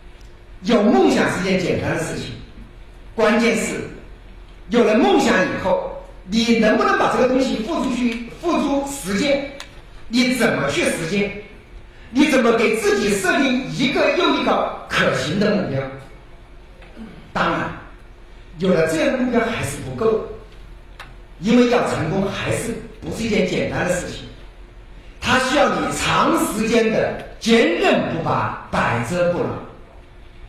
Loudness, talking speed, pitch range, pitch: -19 LUFS, 205 characters per minute, 185-255 Hz, 225 Hz